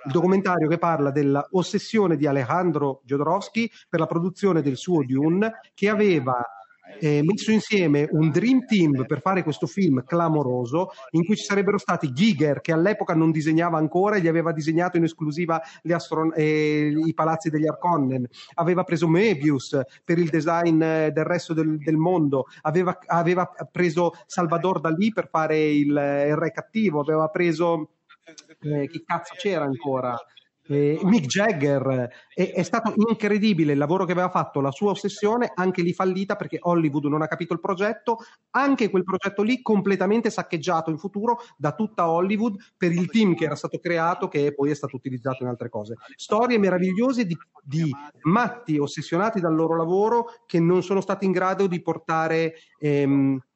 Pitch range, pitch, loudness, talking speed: 155-190 Hz, 170 Hz, -23 LUFS, 165 wpm